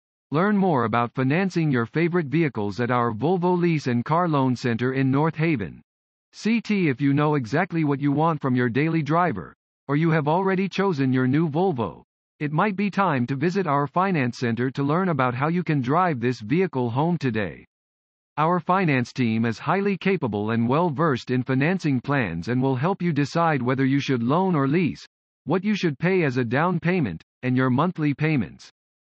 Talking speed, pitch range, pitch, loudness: 190 wpm, 125-175 Hz, 145 Hz, -23 LUFS